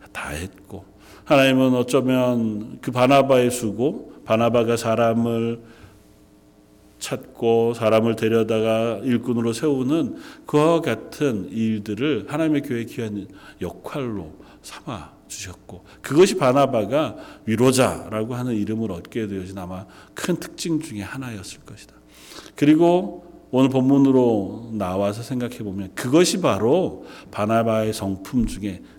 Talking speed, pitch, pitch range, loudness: 265 characters per minute, 115 Hz, 105-135 Hz, -21 LUFS